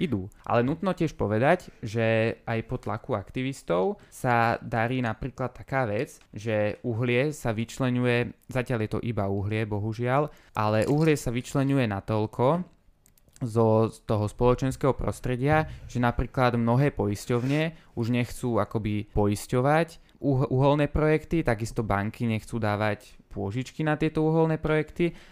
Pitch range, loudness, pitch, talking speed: 110-140 Hz, -27 LUFS, 120 Hz, 130 wpm